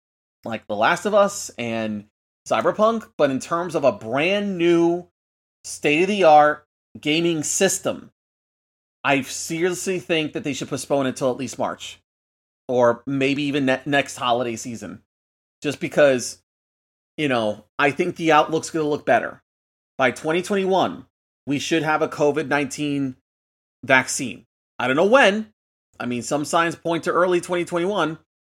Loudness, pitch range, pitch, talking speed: -21 LUFS, 120-170 Hz, 145 Hz, 150 wpm